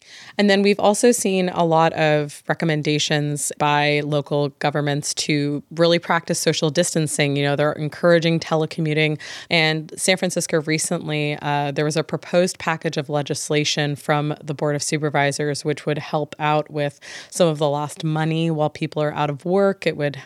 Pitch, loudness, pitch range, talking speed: 155 Hz, -20 LUFS, 150-165 Hz, 170 wpm